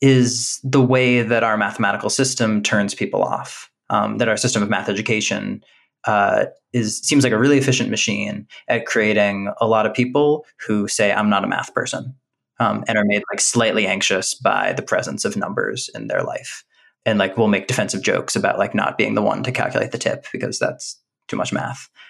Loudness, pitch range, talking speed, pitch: -19 LUFS, 105-130 Hz, 200 wpm, 115 Hz